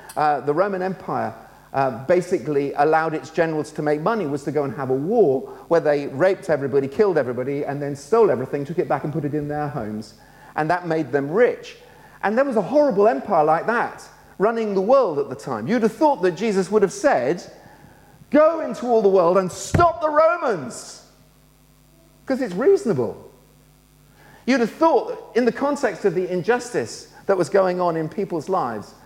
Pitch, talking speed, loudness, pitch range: 185 Hz, 195 wpm, -21 LUFS, 150-235 Hz